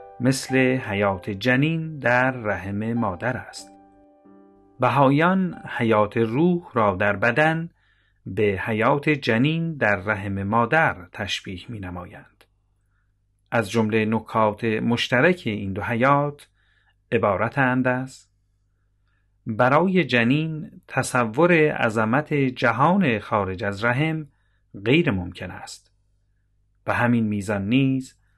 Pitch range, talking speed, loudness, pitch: 100-130 Hz, 95 wpm, -22 LUFS, 115 Hz